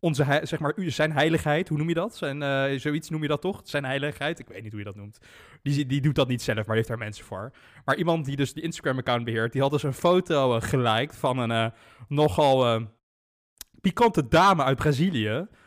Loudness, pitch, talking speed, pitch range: -25 LUFS, 140 Hz, 225 wpm, 115-155 Hz